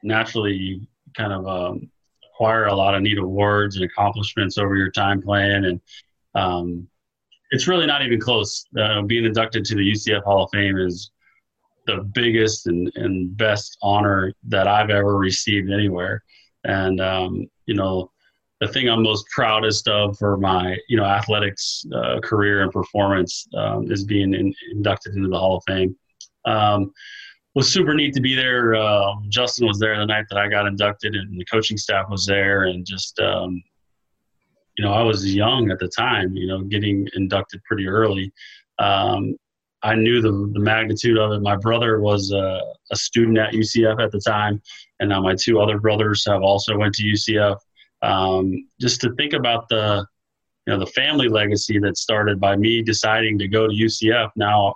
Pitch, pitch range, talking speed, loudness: 105 Hz, 95-110 Hz, 180 wpm, -20 LUFS